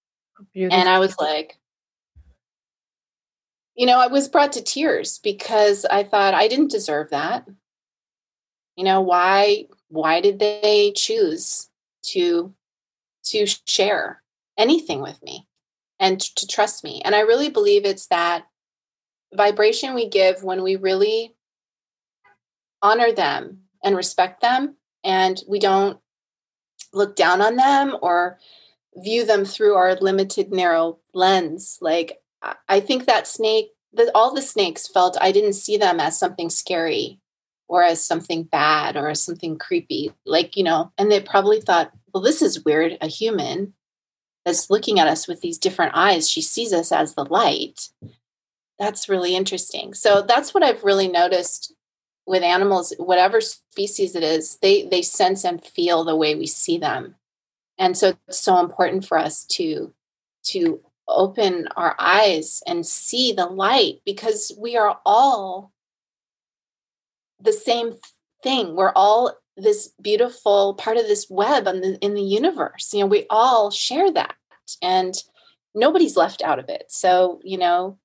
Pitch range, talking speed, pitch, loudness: 185-245 Hz, 150 wpm, 200 Hz, -19 LUFS